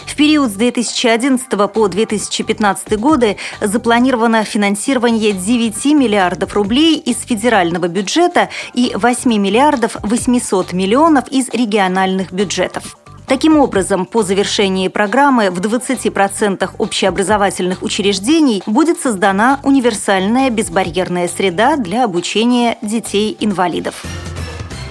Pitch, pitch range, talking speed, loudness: 220 Hz, 195-245 Hz, 95 wpm, -14 LUFS